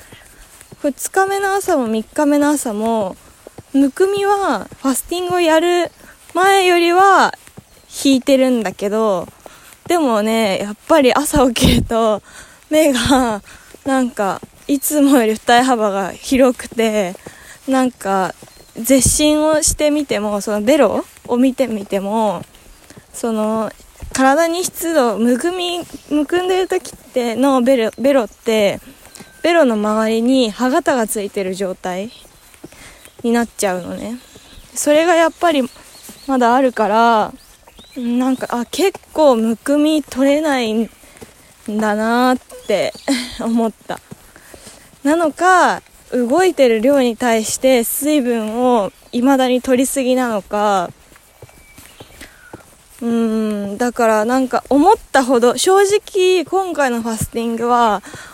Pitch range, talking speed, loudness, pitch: 225-300 Hz, 225 characters per minute, -16 LUFS, 255 Hz